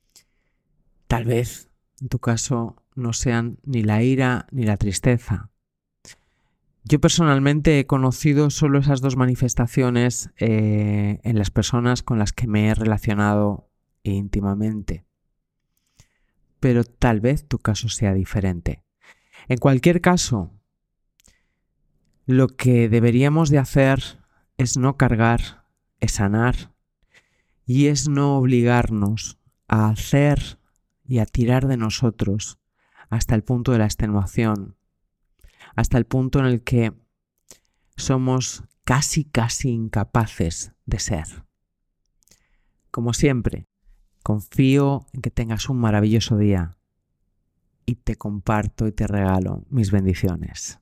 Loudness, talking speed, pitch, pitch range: -21 LUFS, 115 wpm, 115 Hz, 100-130 Hz